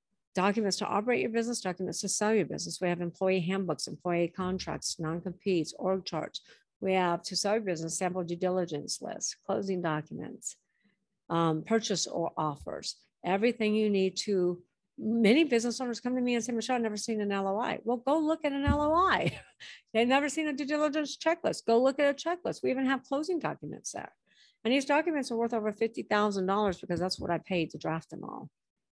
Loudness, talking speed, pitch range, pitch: -31 LUFS, 195 wpm, 185-245 Hz, 205 Hz